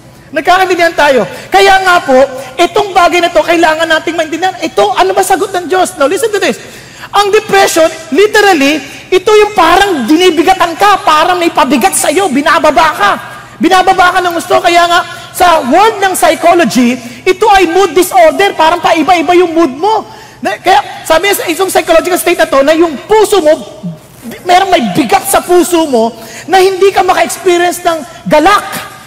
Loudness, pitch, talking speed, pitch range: -8 LUFS, 350 Hz, 165 wpm, 320-380 Hz